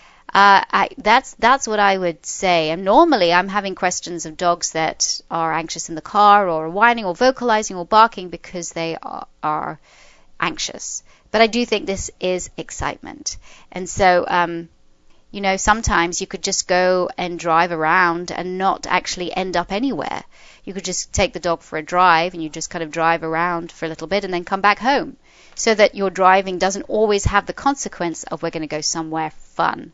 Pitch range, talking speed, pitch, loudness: 170-200 Hz, 200 wpm, 180 Hz, -18 LUFS